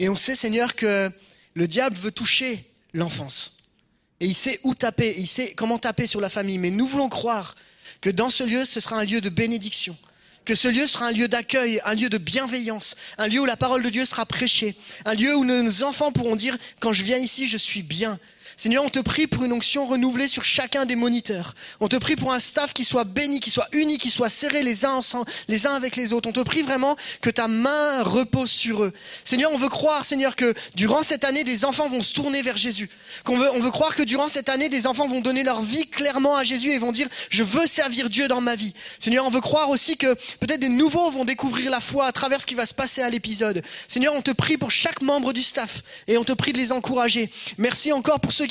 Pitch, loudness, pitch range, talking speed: 250 Hz, -22 LUFS, 225-275 Hz, 250 wpm